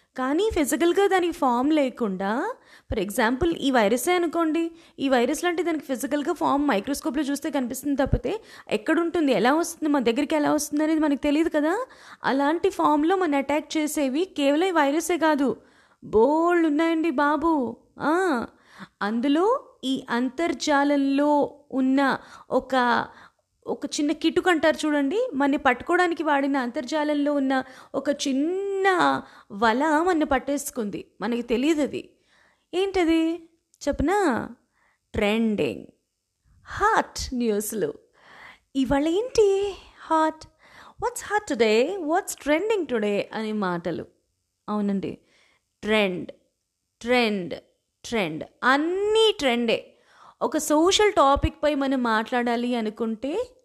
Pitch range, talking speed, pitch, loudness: 255-335 Hz, 105 wpm, 295 Hz, -24 LUFS